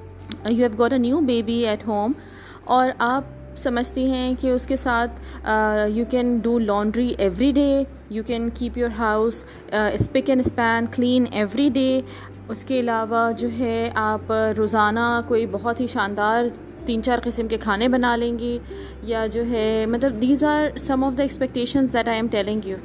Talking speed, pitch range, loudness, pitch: 175 wpm, 220-255 Hz, -22 LUFS, 235 Hz